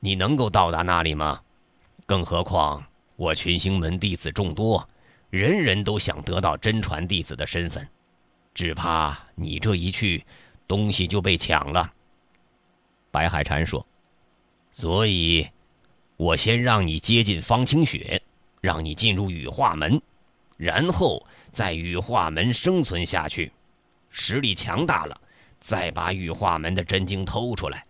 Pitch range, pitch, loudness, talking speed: 80-105 Hz, 90 Hz, -24 LUFS, 200 characters per minute